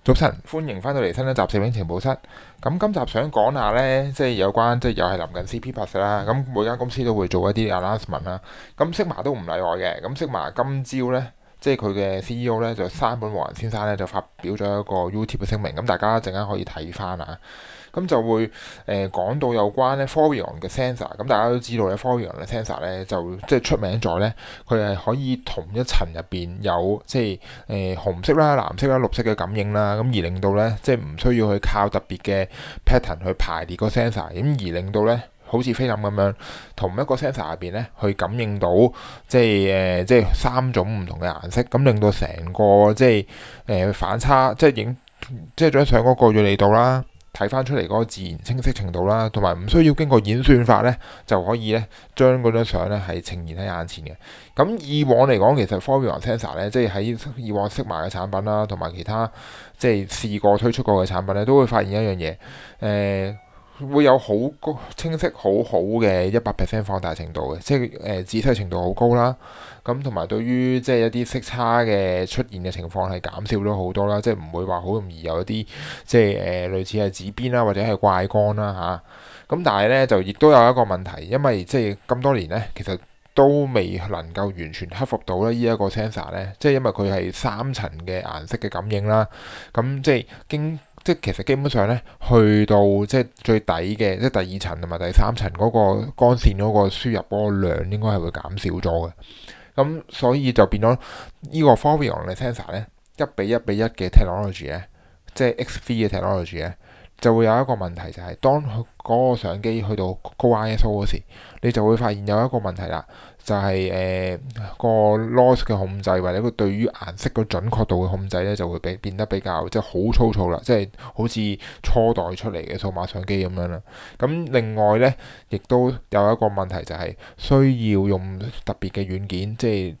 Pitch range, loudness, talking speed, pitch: 95-120 Hz, -21 LUFS, 345 characters per minute, 105 Hz